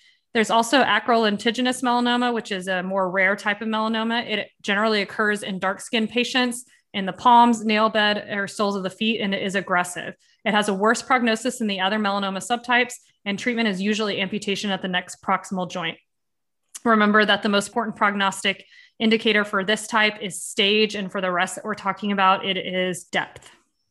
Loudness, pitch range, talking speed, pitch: -22 LUFS, 195-230 Hz, 195 wpm, 210 Hz